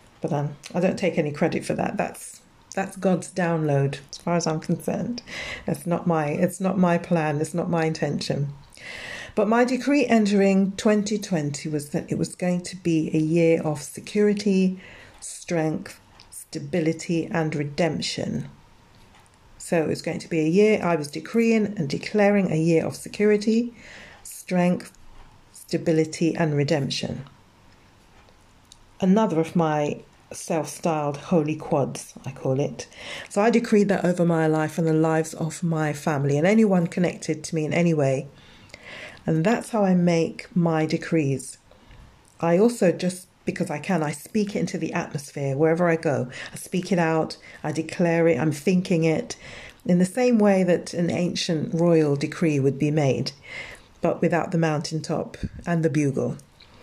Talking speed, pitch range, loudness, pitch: 160 wpm, 150-180 Hz, -24 LUFS, 165 Hz